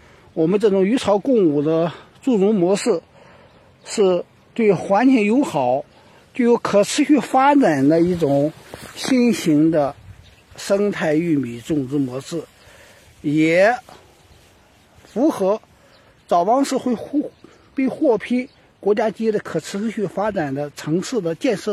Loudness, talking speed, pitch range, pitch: -19 LUFS, 180 characters per minute, 155-240 Hz, 200 Hz